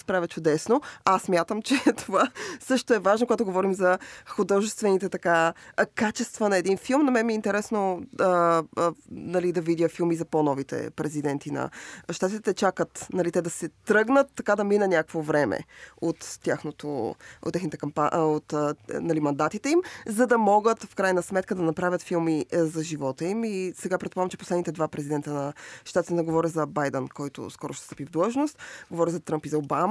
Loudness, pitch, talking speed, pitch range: -26 LUFS, 180 Hz, 185 wpm, 160-205 Hz